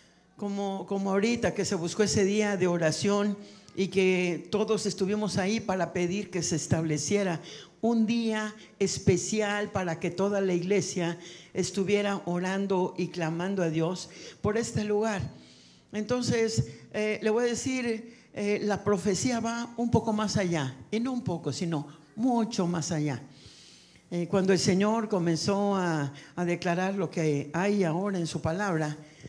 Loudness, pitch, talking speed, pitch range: -29 LUFS, 195 Hz, 150 wpm, 175-210 Hz